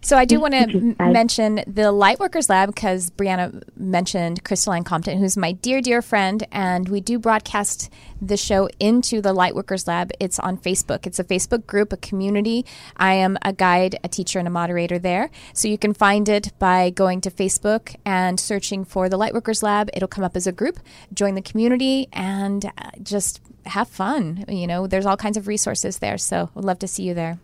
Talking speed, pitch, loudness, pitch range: 200 wpm, 195 Hz, -20 LUFS, 185-210 Hz